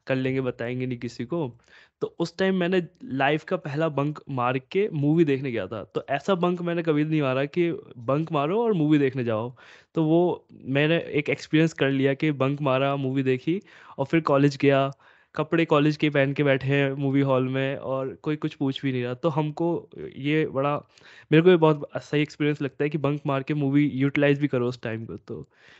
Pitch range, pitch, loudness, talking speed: 135-155 Hz, 140 Hz, -25 LUFS, 210 wpm